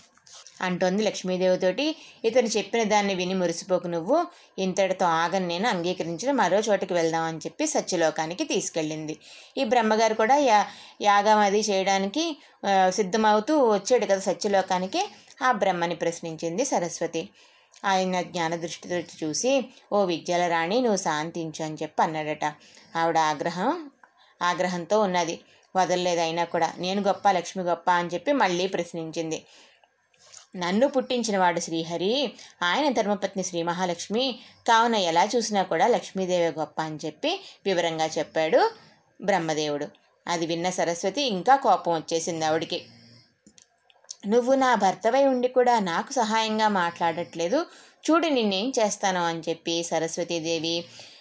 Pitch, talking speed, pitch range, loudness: 185 Hz, 115 wpm, 170-225 Hz, -25 LUFS